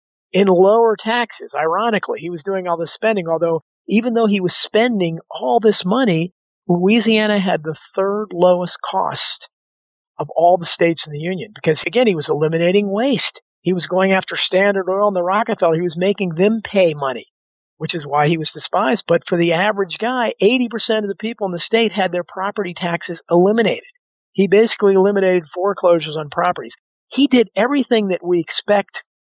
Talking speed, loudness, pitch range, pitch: 180 wpm, -16 LUFS, 170-215 Hz, 190 Hz